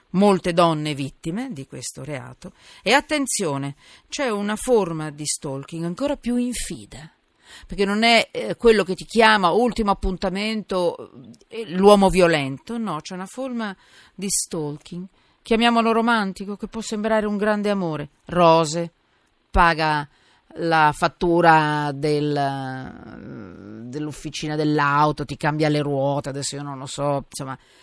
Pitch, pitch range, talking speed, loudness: 170 Hz, 145-210 Hz, 125 wpm, -21 LUFS